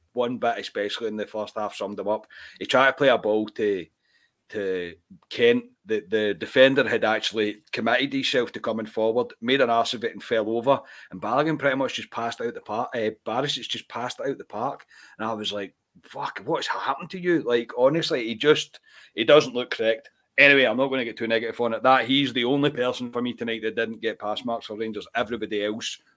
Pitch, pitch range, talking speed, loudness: 120 Hz, 110-140 Hz, 220 wpm, -24 LUFS